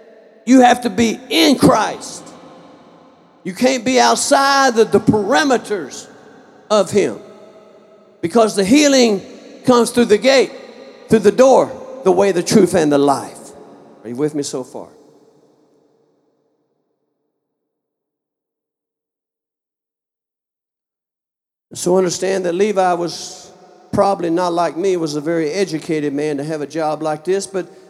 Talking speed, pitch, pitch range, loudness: 125 wpm, 205 Hz, 175-240 Hz, -15 LUFS